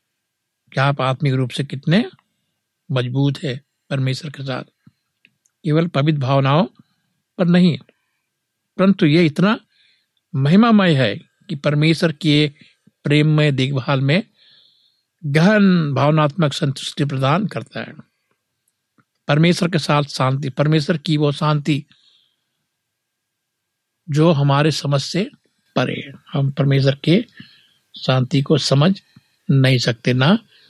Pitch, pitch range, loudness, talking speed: 150 Hz, 135-170 Hz, -18 LUFS, 110 wpm